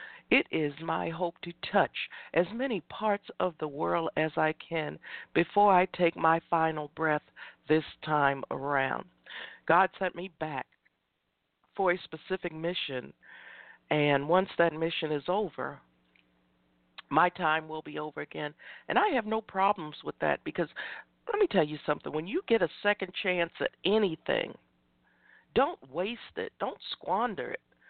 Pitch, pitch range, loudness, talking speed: 160 Hz, 150-185 Hz, -30 LUFS, 155 wpm